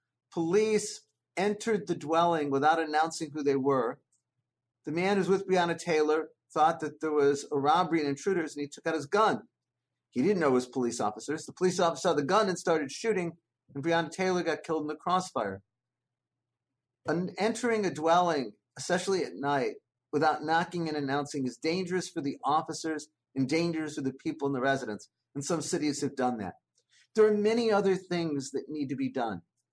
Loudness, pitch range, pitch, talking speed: -30 LUFS, 140-180 Hz, 155 Hz, 190 wpm